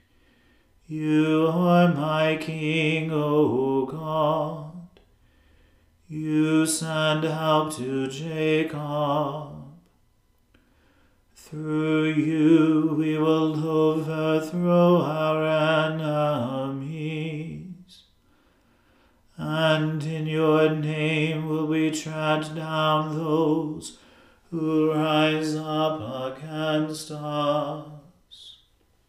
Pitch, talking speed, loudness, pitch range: 155 Hz, 65 wpm, -24 LUFS, 150-155 Hz